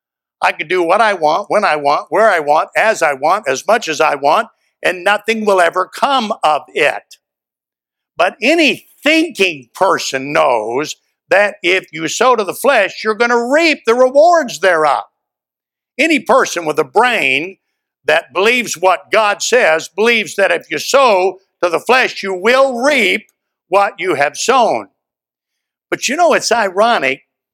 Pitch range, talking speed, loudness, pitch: 180-275 Hz, 165 wpm, -13 LUFS, 215 Hz